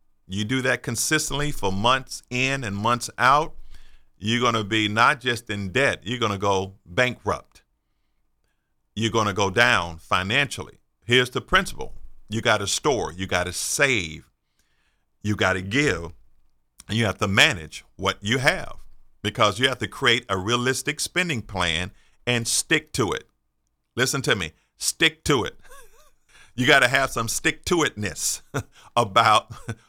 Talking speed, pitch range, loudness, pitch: 160 wpm, 95-125 Hz, -22 LUFS, 110 Hz